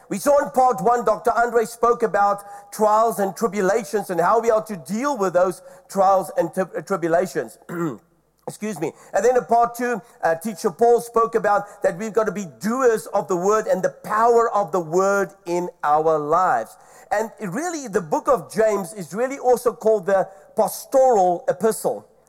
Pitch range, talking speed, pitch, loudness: 190-235 Hz, 185 wpm, 210 Hz, -21 LUFS